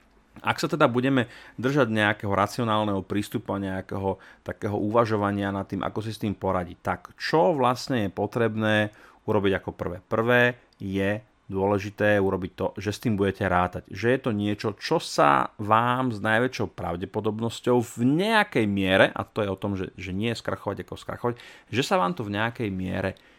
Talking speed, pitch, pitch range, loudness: 175 wpm, 105 Hz, 95-115 Hz, -25 LUFS